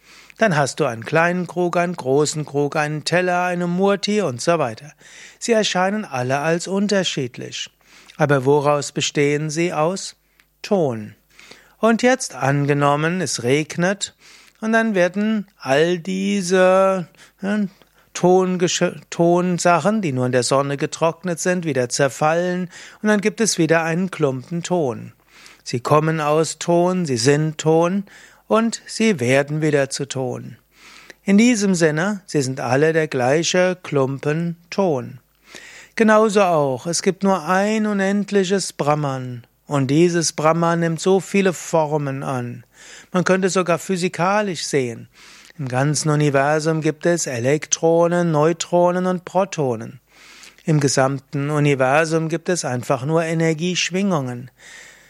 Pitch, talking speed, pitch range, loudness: 165 Hz, 130 wpm, 145-185 Hz, -19 LUFS